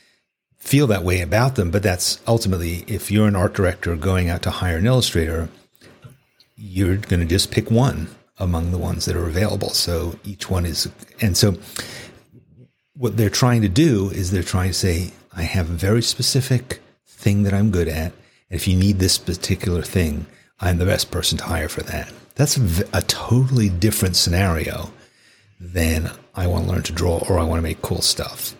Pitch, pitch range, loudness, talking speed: 95 Hz, 90-115 Hz, -20 LUFS, 190 wpm